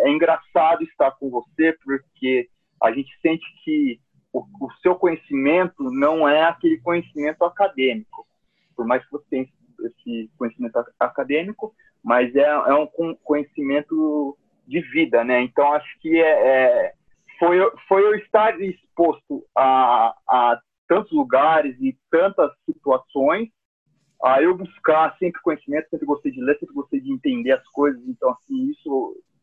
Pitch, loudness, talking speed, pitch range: 165 Hz, -20 LUFS, 145 wpm, 145-225 Hz